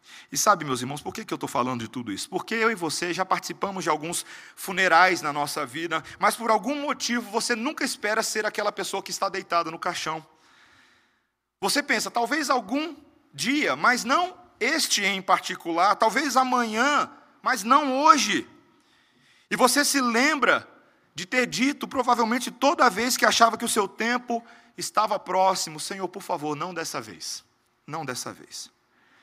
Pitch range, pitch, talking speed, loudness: 175-255 Hz, 215 Hz, 165 wpm, -24 LUFS